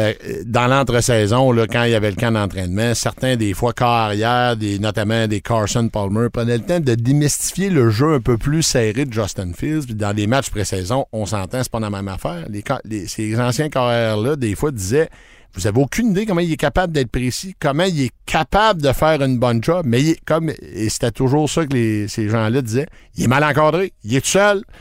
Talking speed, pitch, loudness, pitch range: 225 wpm, 120 Hz, -18 LUFS, 110-145 Hz